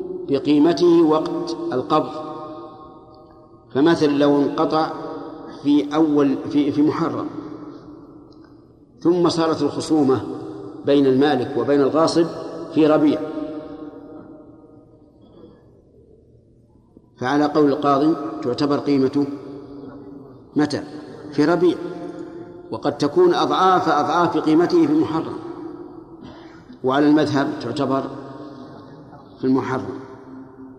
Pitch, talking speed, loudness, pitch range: 155 Hz, 80 wpm, -19 LUFS, 140-160 Hz